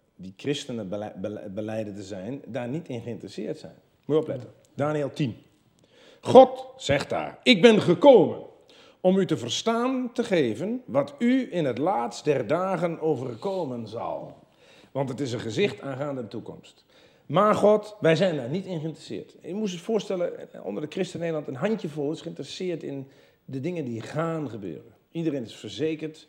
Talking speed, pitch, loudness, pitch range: 165 wpm, 160 Hz, -25 LUFS, 130-205 Hz